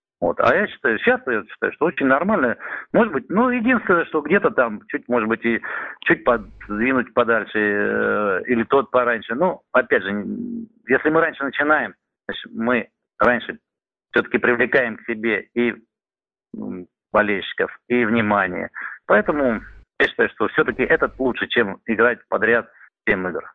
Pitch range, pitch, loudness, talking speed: 115-160 Hz, 120 Hz, -20 LUFS, 145 wpm